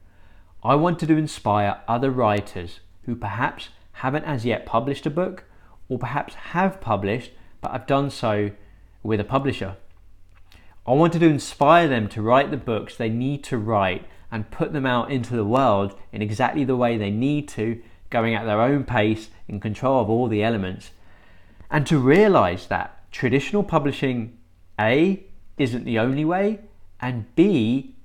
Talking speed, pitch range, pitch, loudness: 165 wpm, 100-140 Hz, 115 Hz, -22 LUFS